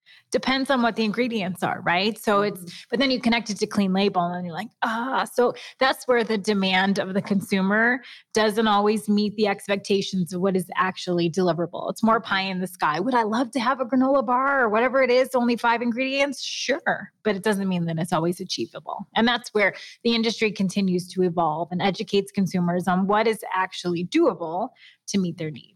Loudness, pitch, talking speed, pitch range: -23 LUFS, 205 Hz, 210 wpm, 185-235 Hz